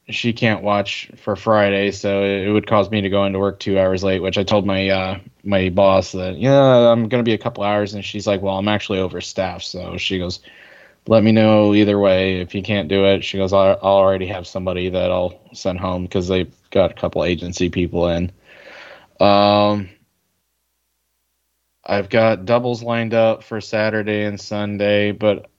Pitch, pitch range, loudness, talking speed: 100 Hz, 95-105 Hz, -18 LUFS, 195 wpm